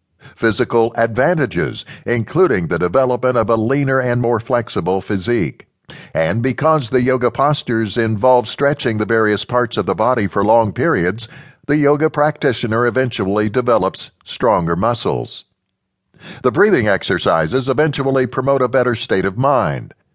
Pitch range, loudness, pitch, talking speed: 115-135 Hz, -16 LUFS, 125 Hz, 135 wpm